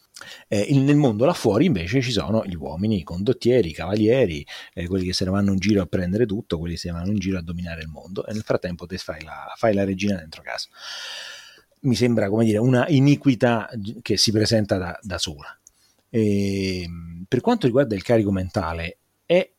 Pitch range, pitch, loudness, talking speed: 90-115 Hz, 100 Hz, -22 LUFS, 205 wpm